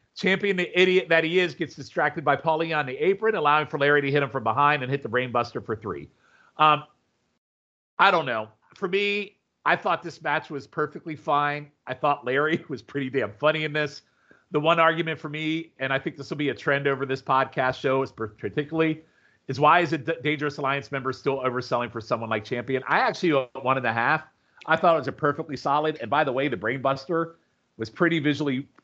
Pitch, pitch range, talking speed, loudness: 145 Hz, 135-160 Hz, 215 wpm, -25 LUFS